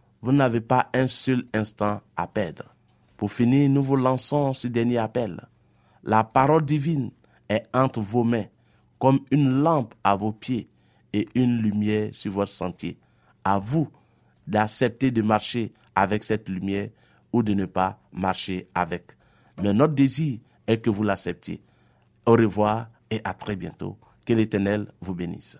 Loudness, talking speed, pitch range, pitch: -24 LUFS, 155 wpm, 105-130 Hz, 115 Hz